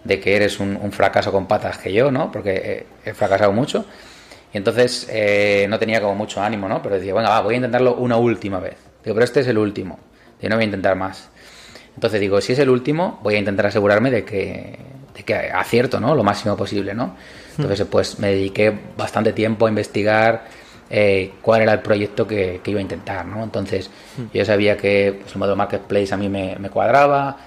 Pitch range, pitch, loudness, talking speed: 100-110 Hz, 105 Hz, -19 LUFS, 215 wpm